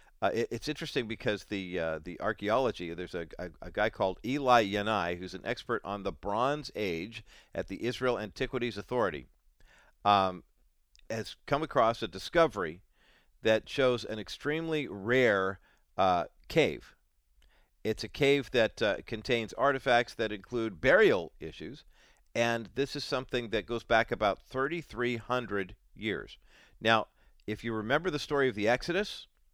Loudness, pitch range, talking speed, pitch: -31 LUFS, 100-130 Hz, 145 wpm, 115 Hz